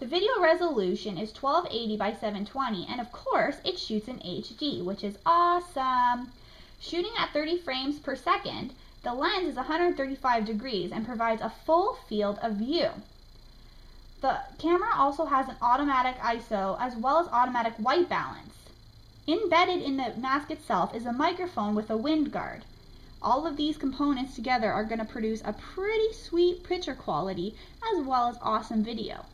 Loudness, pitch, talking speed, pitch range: -29 LUFS, 260 Hz, 160 wpm, 225-330 Hz